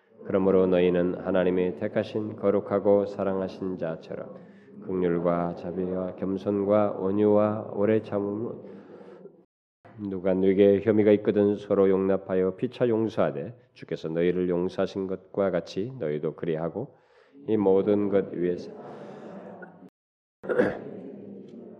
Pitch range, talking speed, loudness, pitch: 90-105 Hz, 255 characters per minute, -26 LUFS, 95 Hz